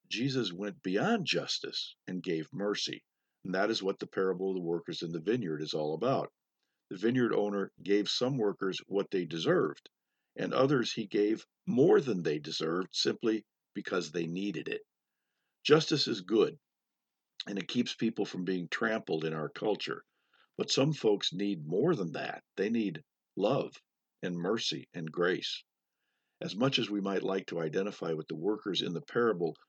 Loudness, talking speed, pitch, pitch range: -32 LUFS, 170 wpm, 100 Hz, 85-115 Hz